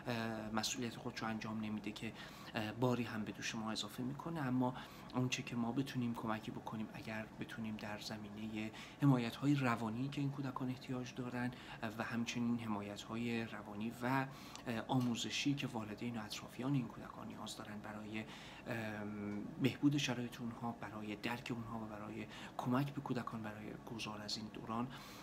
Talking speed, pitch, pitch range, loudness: 145 wpm, 115 Hz, 110-125 Hz, -42 LUFS